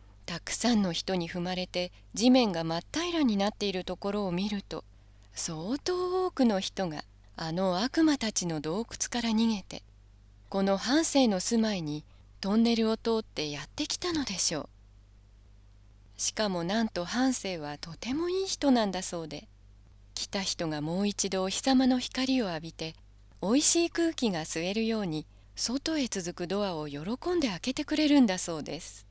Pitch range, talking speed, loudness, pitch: 155-245 Hz, 310 characters per minute, -29 LUFS, 190 Hz